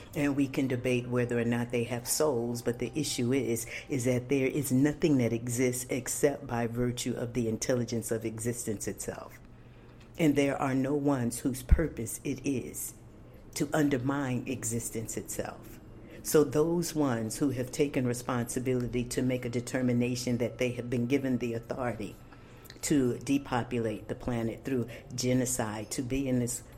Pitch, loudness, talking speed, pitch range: 125 Hz, -31 LUFS, 160 wpm, 120-140 Hz